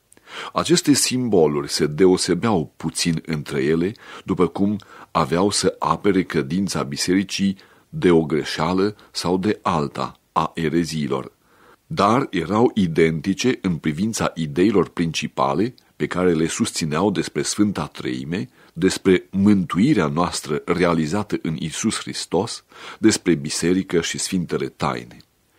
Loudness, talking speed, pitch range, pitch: -21 LUFS, 115 wpm, 80-100 Hz, 90 Hz